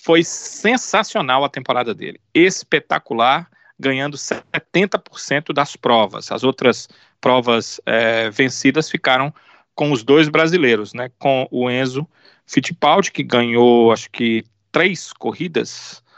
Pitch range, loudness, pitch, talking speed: 125-160 Hz, -17 LUFS, 135 Hz, 115 wpm